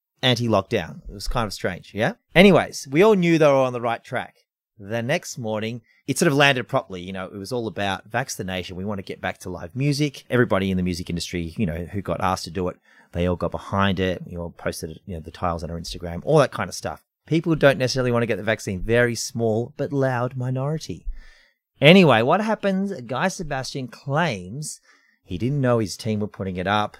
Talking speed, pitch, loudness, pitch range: 225 wpm, 110 Hz, -22 LUFS, 90-130 Hz